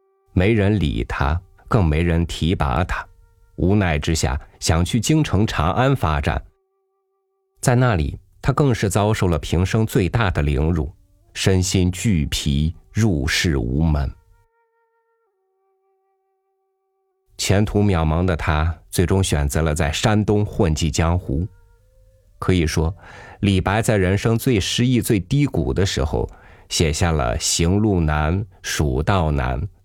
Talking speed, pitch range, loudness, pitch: 180 characters per minute, 80-115 Hz, -20 LUFS, 95 Hz